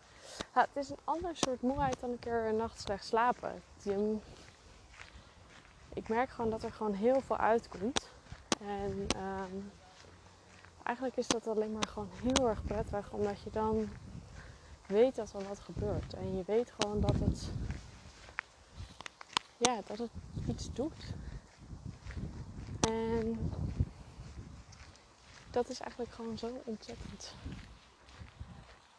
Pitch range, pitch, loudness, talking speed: 200-245 Hz, 220 Hz, -36 LUFS, 125 wpm